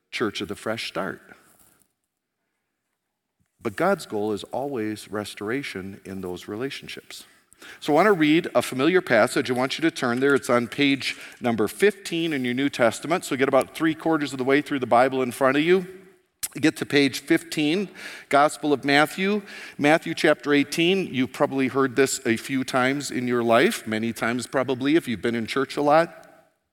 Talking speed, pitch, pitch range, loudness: 190 wpm, 140 Hz, 125-160 Hz, -23 LUFS